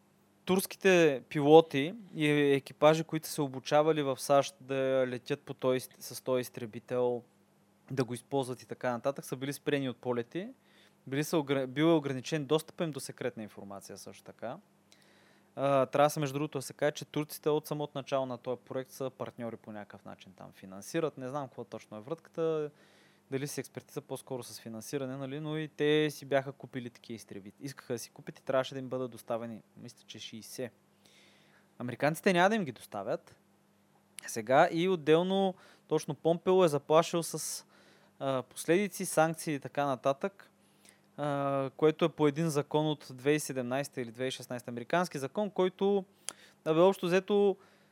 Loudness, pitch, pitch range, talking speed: -32 LUFS, 140 Hz, 125-160 Hz, 160 wpm